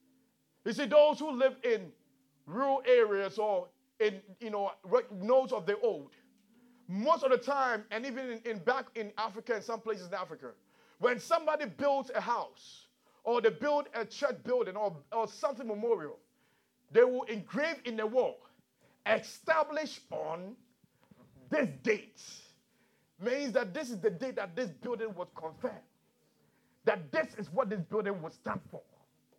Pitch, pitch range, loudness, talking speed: 240 Hz, 215-275 Hz, -33 LUFS, 155 wpm